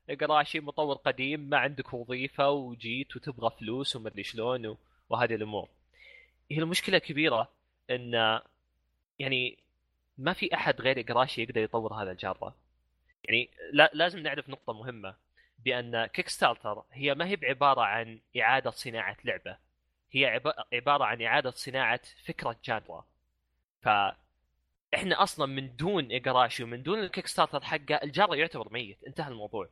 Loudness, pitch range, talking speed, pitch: -30 LUFS, 110-145 Hz, 130 wpm, 125 Hz